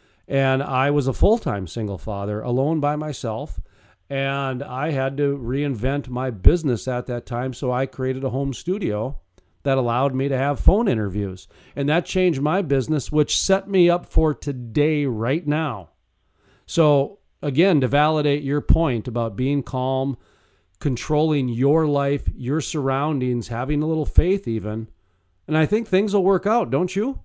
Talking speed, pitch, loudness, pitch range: 165 wpm, 135 Hz, -22 LUFS, 120-150 Hz